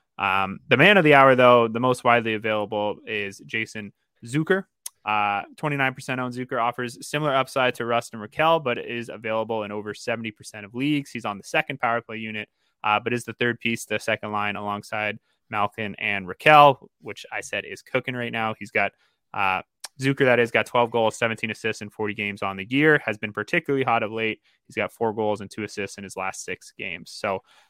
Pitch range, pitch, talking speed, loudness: 105-125 Hz, 115 Hz, 210 wpm, -23 LUFS